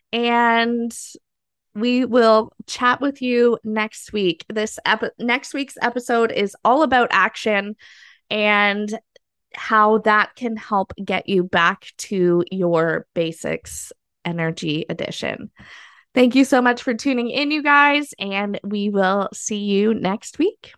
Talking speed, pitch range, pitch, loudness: 135 wpm, 195-245 Hz, 220 Hz, -19 LUFS